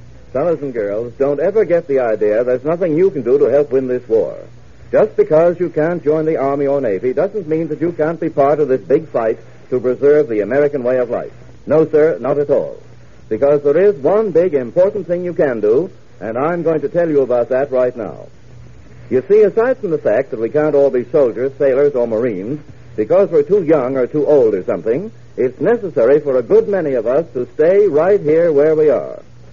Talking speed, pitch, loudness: 220 wpm, 170 Hz, -15 LUFS